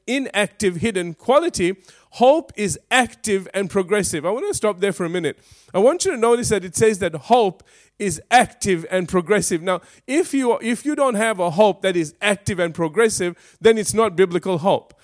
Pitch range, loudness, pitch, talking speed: 185-235 Hz, -19 LUFS, 205 Hz, 195 wpm